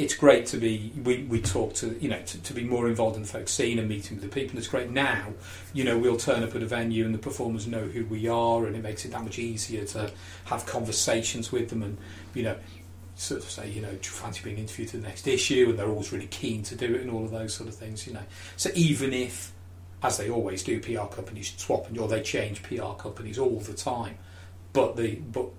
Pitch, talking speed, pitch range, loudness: 110 Hz, 255 wpm, 95-115 Hz, -29 LUFS